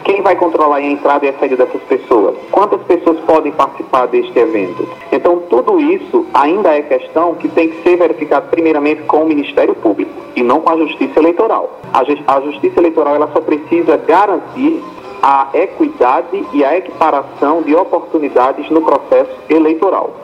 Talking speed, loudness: 165 wpm, -12 LUFS